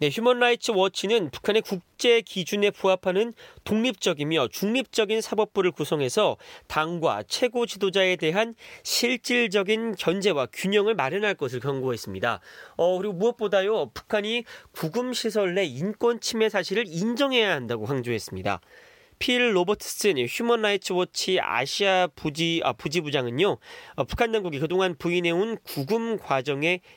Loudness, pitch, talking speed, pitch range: -25 LUFS, 200 Hz, 325 characters per minute, 170-225 Hz